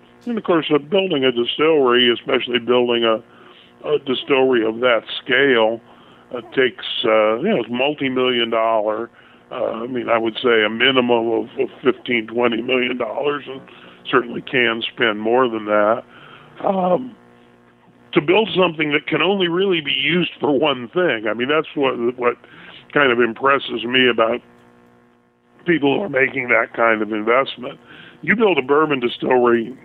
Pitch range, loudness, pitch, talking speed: 110-140 Hz, -18 LUFS, 120 Hz, 160 wpm